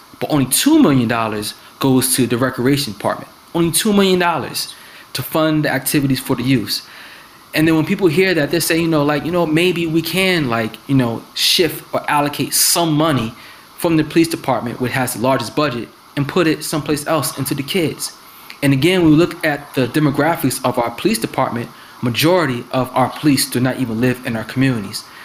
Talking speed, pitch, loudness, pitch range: 195 wpm, 145 Hz, -16 LUFS, 130-165 Hz